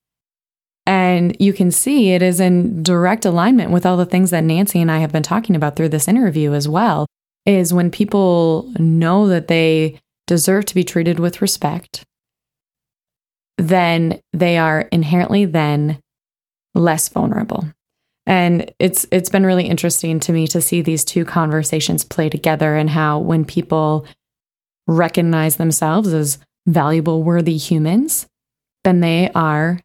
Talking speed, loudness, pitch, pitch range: 145 wpm, -16 LUFS, 170 Hz, 160-185 Hz